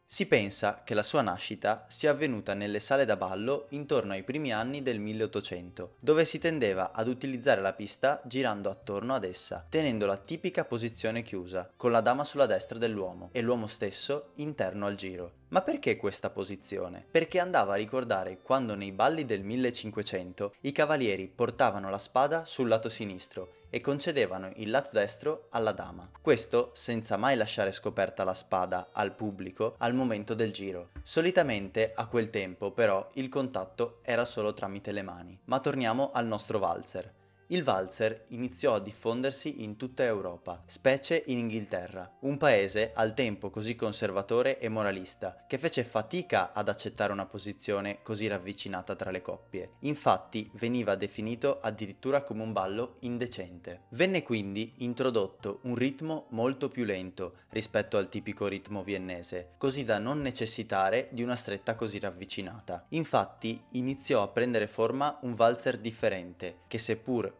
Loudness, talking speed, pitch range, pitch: -31 LUFS, 155 wpm, 100-130 Hz, 110 Hz